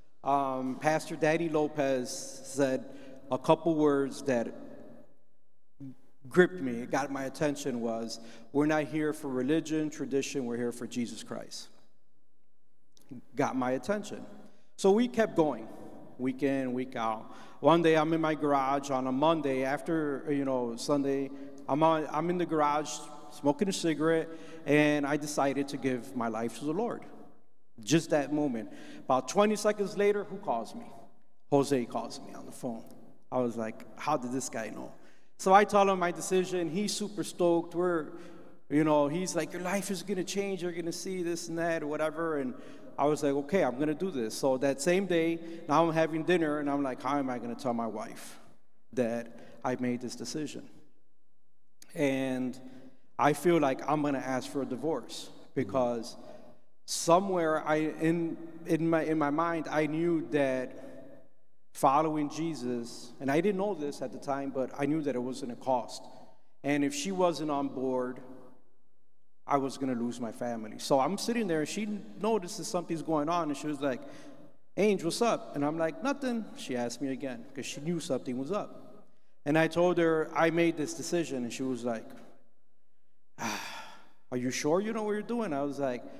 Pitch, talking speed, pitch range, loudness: 150 Hz, 180 wpm, 130-165 Hz, -31 LUFS